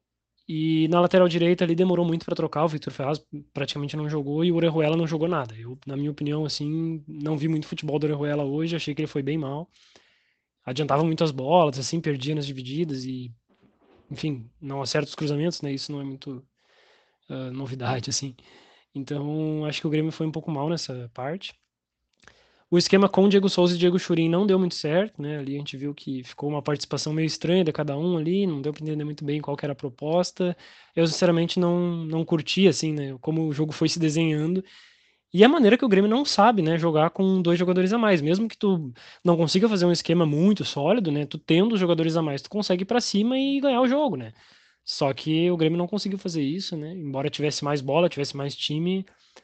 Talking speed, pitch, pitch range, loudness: 220 wpm, 160 Hz, 145-175 Hz, -24 LUFS